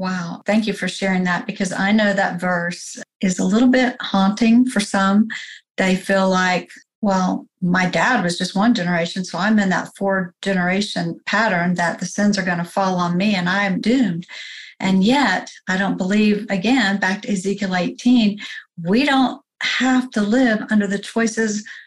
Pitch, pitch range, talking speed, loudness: 200 Hz, 185-220 Hz, 180 wpm, -19 LUFS